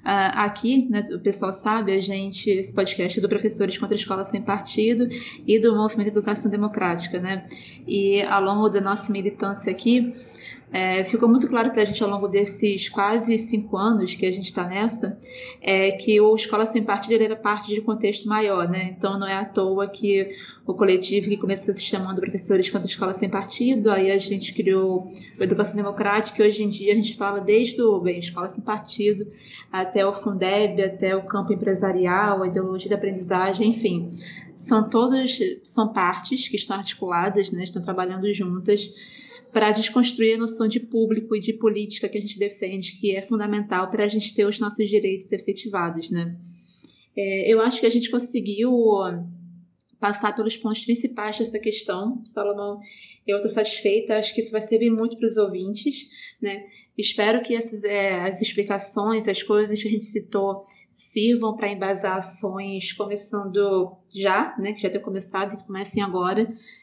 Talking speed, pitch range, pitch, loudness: 180 wpm, 195-220 Hz, 205 Hz, -23 LUFS